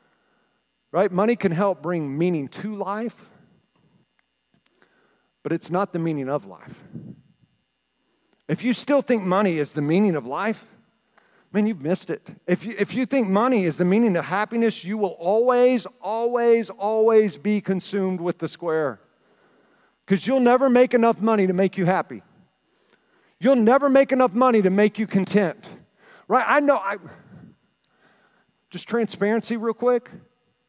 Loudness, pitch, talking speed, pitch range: -22 LUFS, 210 Hz, 150 wpm, 185-230 Hz